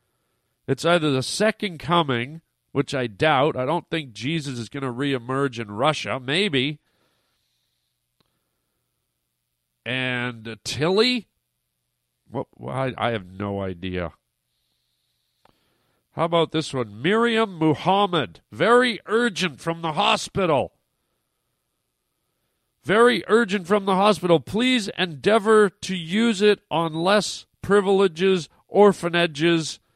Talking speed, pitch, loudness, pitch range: 105 wpm, 160 Hz, -22 LUFS, 125-195 Hz